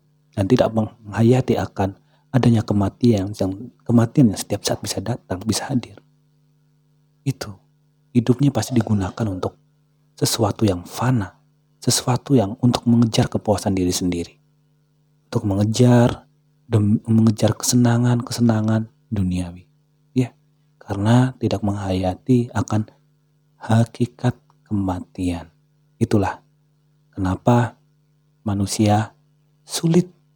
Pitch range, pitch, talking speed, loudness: 105-150 Hz, 120 Hz, 95 wpm, -20 LUFS